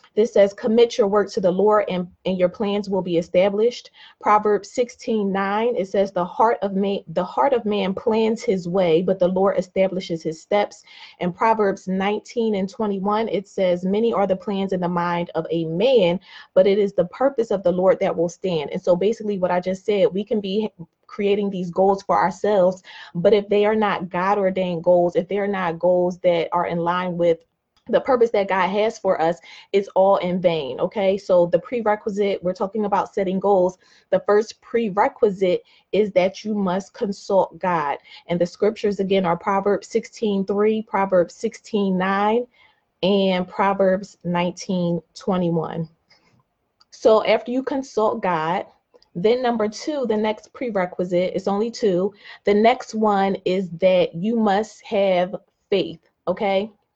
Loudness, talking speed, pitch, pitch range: -21 LUFS, 175 wpm, 195 Hz, 180-210 Hz